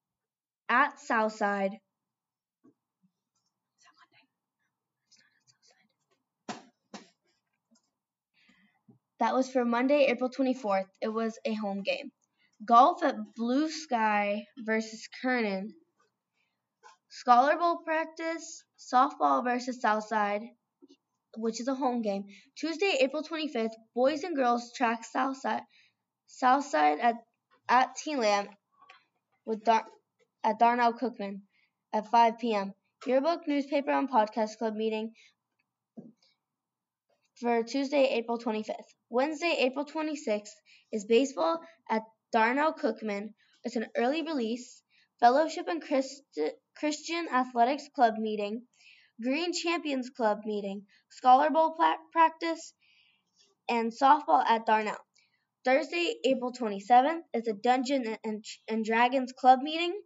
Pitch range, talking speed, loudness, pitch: 220-285 Hz, 100 wpm, -29 LUFS, 245 Hz